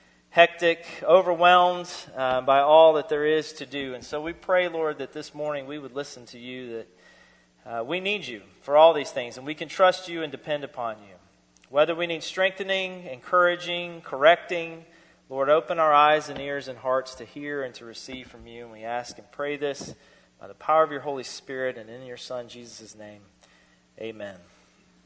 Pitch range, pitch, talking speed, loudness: 120-165 Hz, 145 Hz, 195 wpm, -24 LUFS